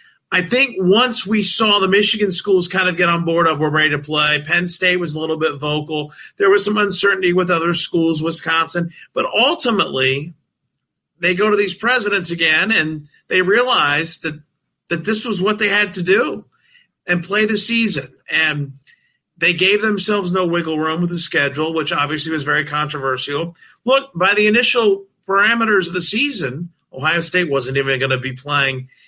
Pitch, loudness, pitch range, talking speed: 175 Hz, -17 LUFS, 155-205 Hz, 180 wpm